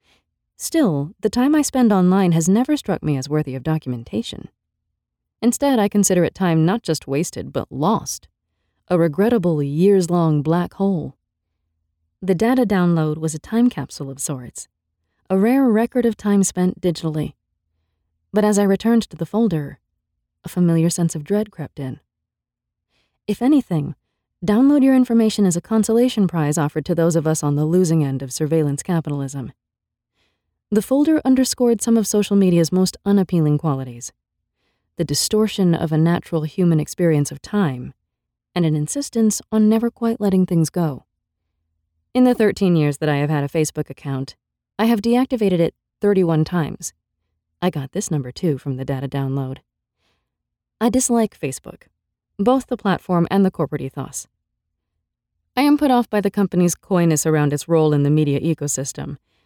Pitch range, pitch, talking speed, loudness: 140-205 Hz, 165 Hz, 160 wpm, -19 LUFS